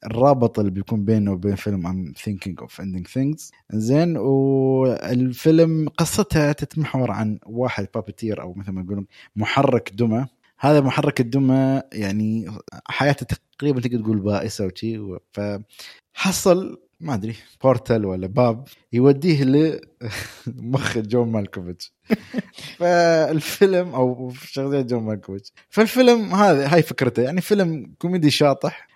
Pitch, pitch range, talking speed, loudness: 125 Hz, 105-145 Hz, 120 wpm, -21 LUFS